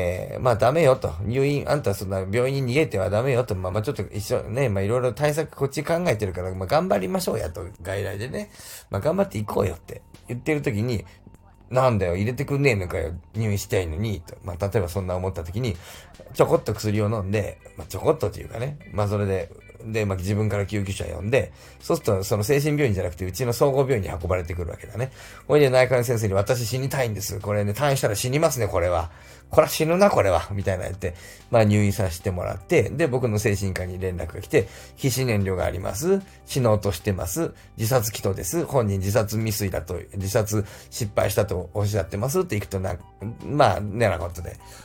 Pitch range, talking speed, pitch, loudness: 95-125 Hz, 435 characters per minute, 105 Hz, -24 LUFS